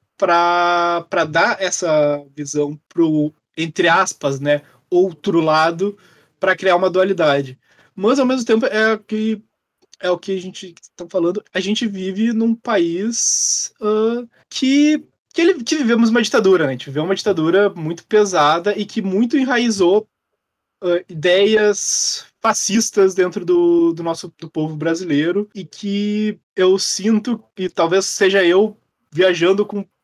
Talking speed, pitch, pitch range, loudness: 145 wpm, 190 Hz, 170-215 Hz, -17 LUFS